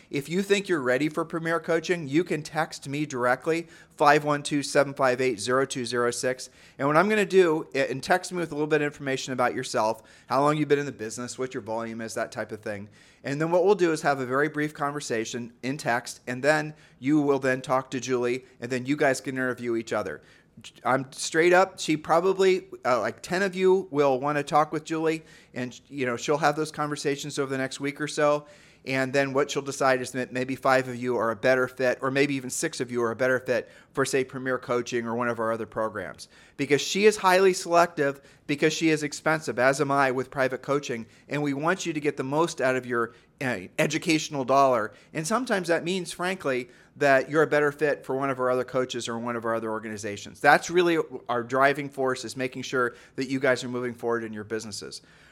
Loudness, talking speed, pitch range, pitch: -26 LUFS, 225 wpm, 125-155 Hz, 140 Hz